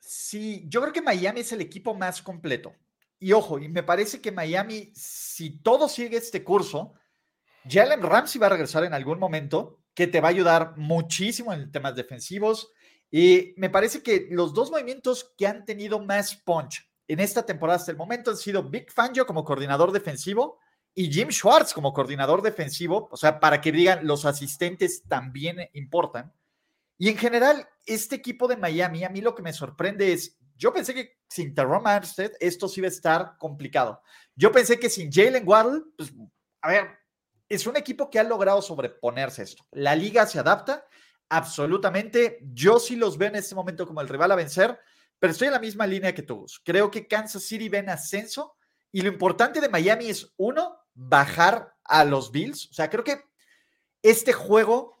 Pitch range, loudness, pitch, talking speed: 165-230 Hz, -24 LUFS, 195 Hz, 185 wpm